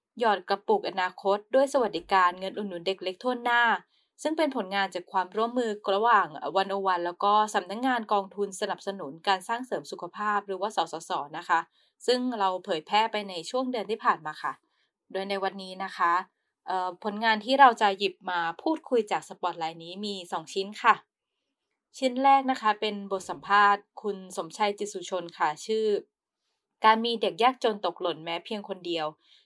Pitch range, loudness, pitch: 185-225 Hz, -27 LUFS, 200 Hz